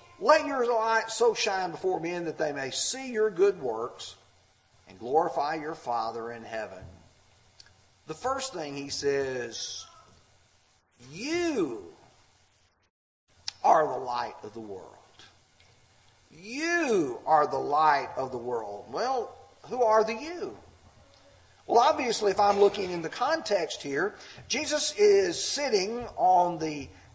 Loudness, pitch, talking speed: -28 LUFS, 175 Hz, 130 wpm